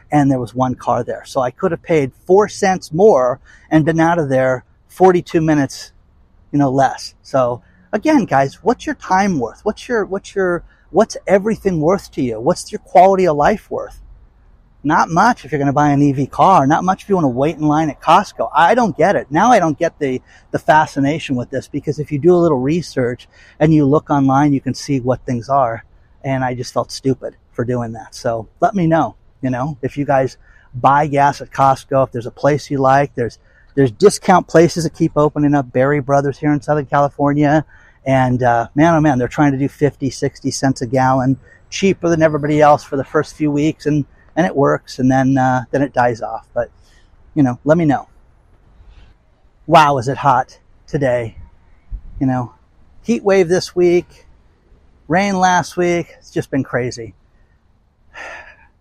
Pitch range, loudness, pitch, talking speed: 125-160 Hz, -16 LUFS, 140 Hz, 200 wpm